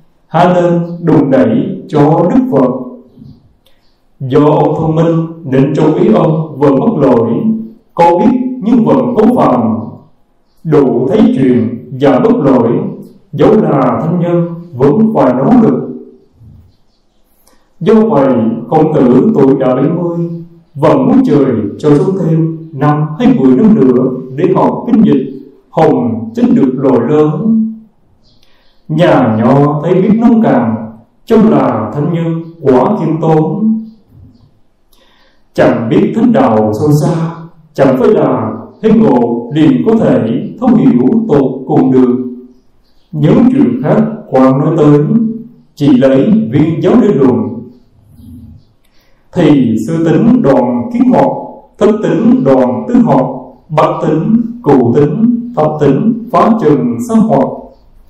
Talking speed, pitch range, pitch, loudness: 135 wpm, 135-220 Hz, 160 Hz, -9 LUFS